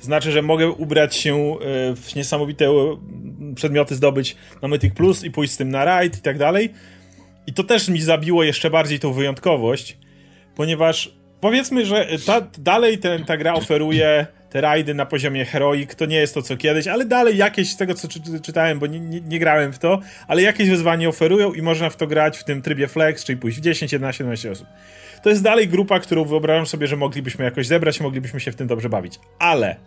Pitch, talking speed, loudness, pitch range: 155 Hz, 210 wpm, -19 LUFS, 140-170 Hz